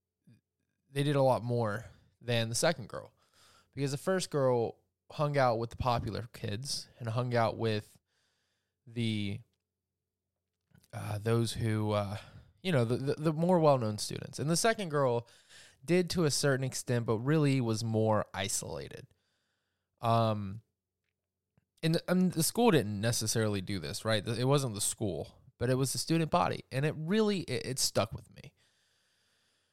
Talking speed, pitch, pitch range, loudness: 160 wpm, 115 Hz, 105-145 Hz, -32 LUFS